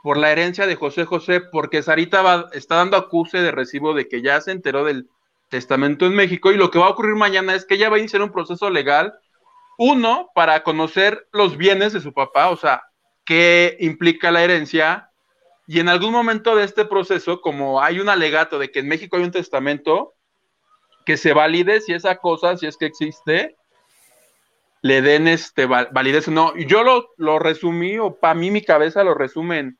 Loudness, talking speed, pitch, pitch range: -17 LUFS, 195 wpm, 175 Hz, 155-195 Hz